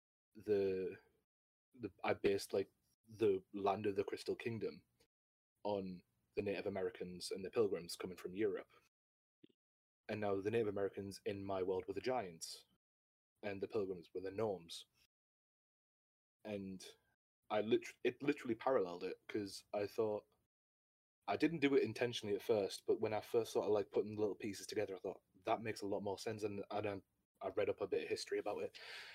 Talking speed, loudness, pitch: 175 wpm, -42 LUFS, 110 Hz